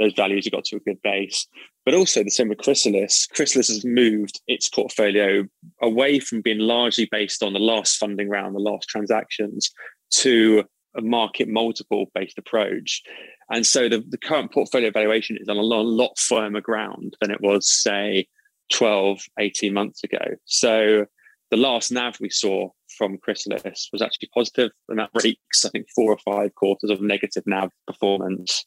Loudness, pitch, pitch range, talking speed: -21 LUFS, 105 Hz, 100-115 Hz, 175 wpm